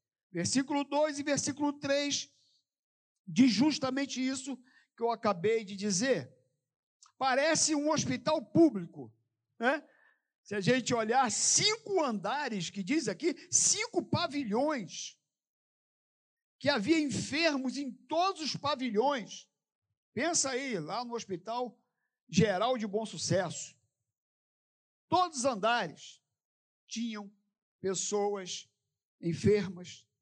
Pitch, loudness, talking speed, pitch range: 240 Hz, -31 LUFS, 100 wpm, 190-285 Hz